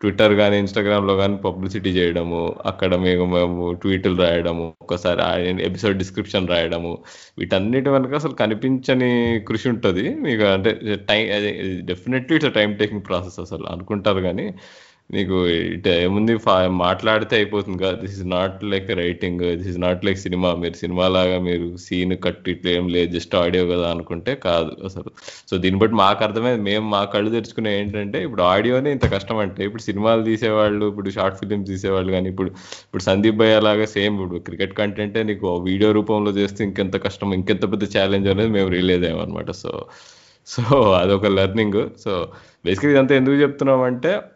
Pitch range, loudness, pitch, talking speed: 90-105 Hz, -20 LUFS, 100 Hz, 160 wpm